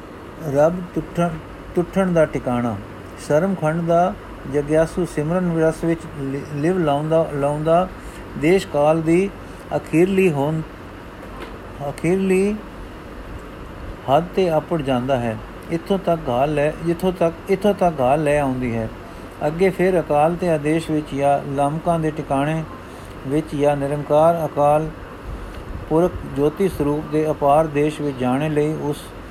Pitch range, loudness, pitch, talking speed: 140-170 Hz, -20 LUFS, 150 Hz, 125 wpm